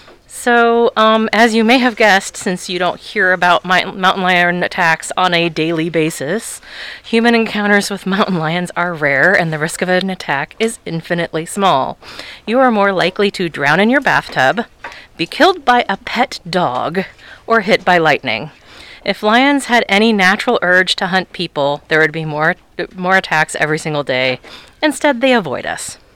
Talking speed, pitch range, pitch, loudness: 175 wpm, 170-225 Hz, 185 Hz, -14 LUFS